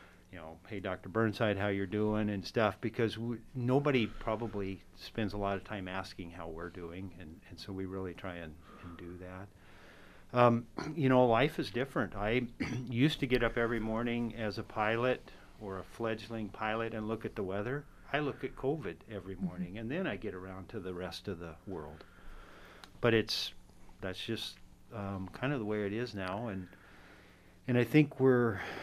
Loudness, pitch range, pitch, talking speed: -35 LUFS, 95-115 Hz, 105 Hz, 190 wpm